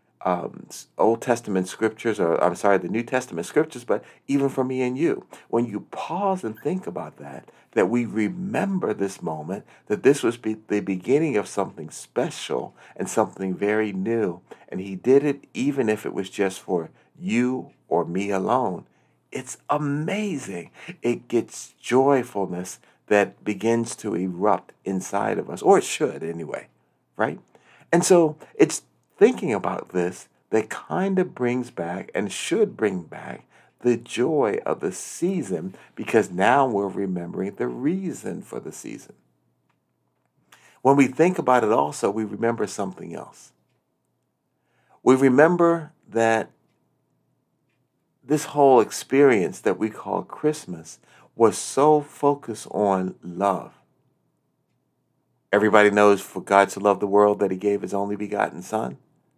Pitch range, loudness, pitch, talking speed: 100-135 Hz, -23 LUFS, 110 Hz, 145 wpm